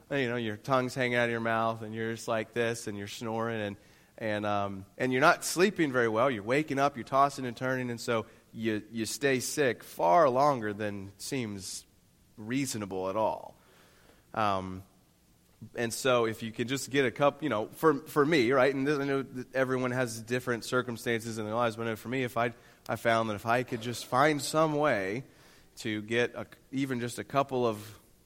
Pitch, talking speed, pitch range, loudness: 120 Hz, 205 wpm, 110-130 Hz, -30 LUFS